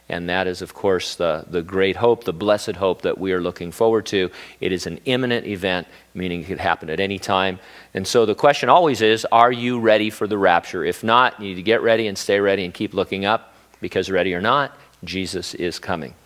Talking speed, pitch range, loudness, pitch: 235 wpm, 90-115 Hz, -20 LUFS, 100 Hz